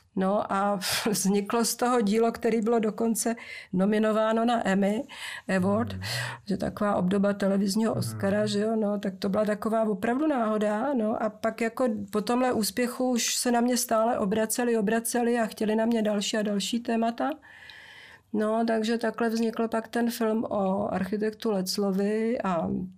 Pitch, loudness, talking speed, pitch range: 220 Hz, -27 LUFS, 155 wpm, 205-230 Hz